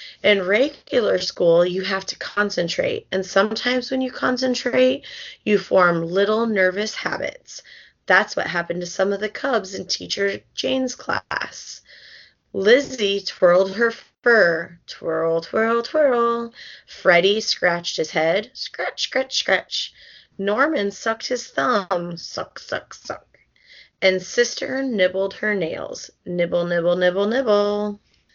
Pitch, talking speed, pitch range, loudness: 205 Hz, 125 wpm, 180-240 Hz, -21 LUFS